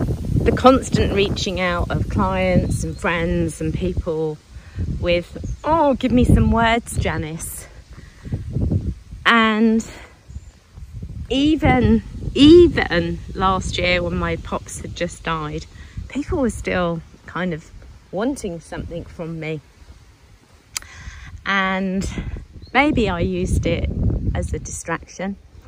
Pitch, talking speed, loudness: 165 Hz, 105 wpm, -19 LUFS